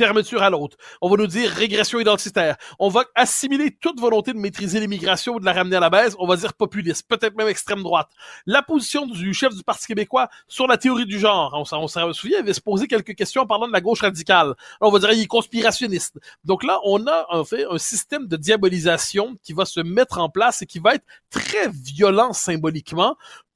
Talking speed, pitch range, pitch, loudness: 225 wpm, 185-240 Hz, 210 Hz, -20 LUFS